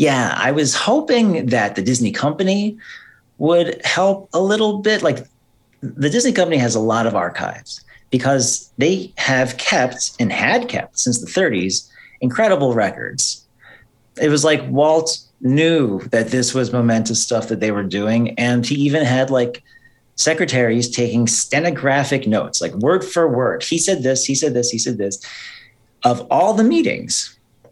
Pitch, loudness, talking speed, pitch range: 130 Hz, -17 LUFS, 160 wpm, 120-160 Hz